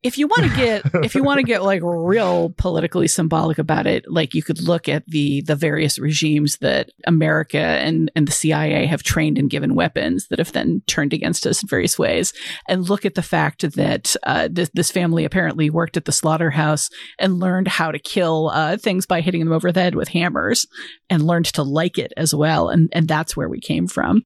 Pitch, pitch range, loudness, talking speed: 165 Hz, 155-180 Hz, -19 LUFS, 220 wpm